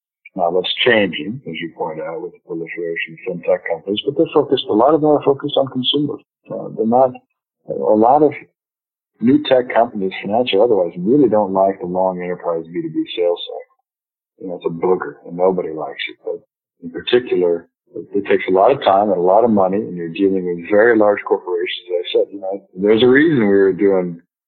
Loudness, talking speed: -17 LUFS, 210 wpm